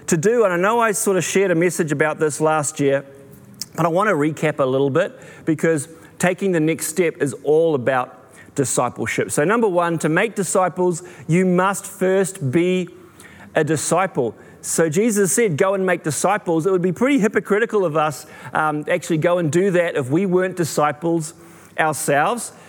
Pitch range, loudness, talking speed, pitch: 155-190 Hz, -19 LUFS, 185 wpm, 170 Hz